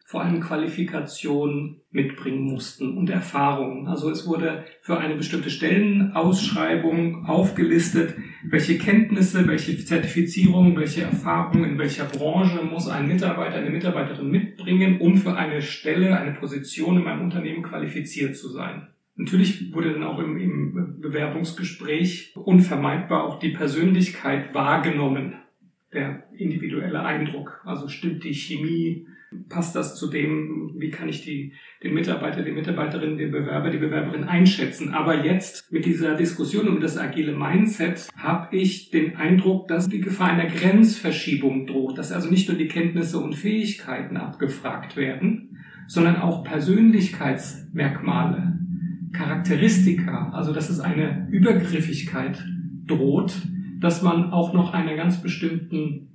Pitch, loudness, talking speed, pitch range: 165 Hz, -23 LUFS, 130 wpm, 155-180 Hz